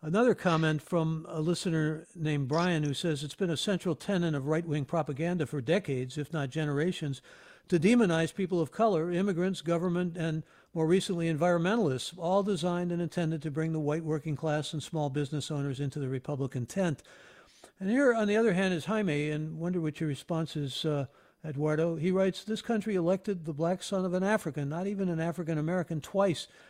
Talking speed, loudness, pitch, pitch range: 190 wpm, -31 LUFS, 165 Hz, 150-185 Hz